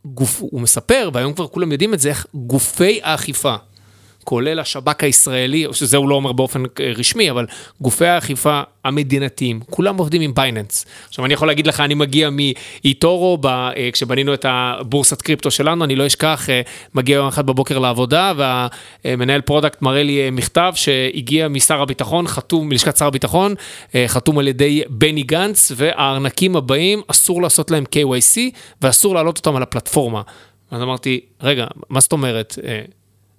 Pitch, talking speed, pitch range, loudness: 140 Hz, 150 wpm, 130-155 Hz, -15 LUFS